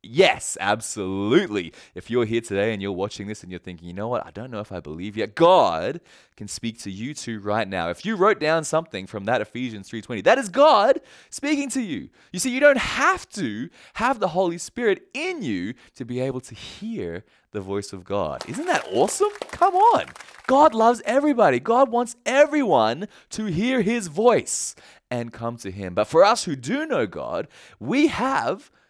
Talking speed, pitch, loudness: 195 wpm, 135 Hz, -22 LUFS